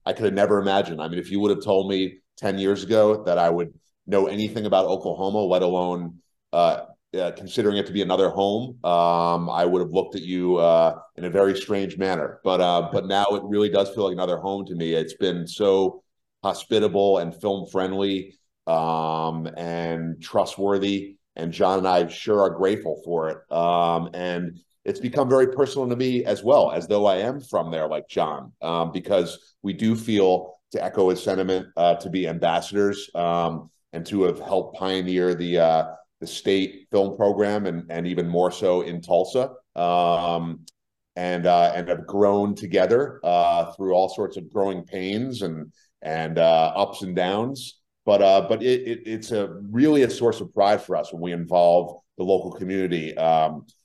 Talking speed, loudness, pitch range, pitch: 190 wpm, -23 LUFS, 85-100 Hz, 95 Hz